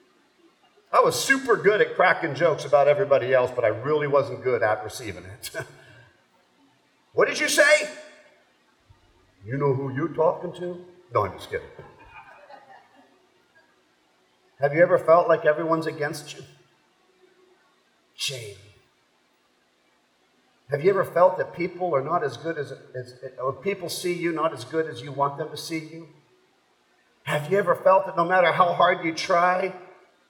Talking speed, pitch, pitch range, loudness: 155 wpm, 165 Hz, 140-185 Hz, -23 LUFS